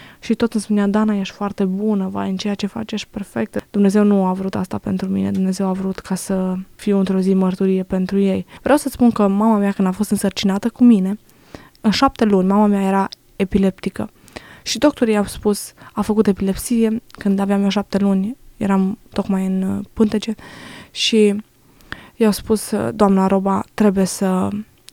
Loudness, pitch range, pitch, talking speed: -18 LUFS, 195-215 Hz, 200 Hz, 180 wpm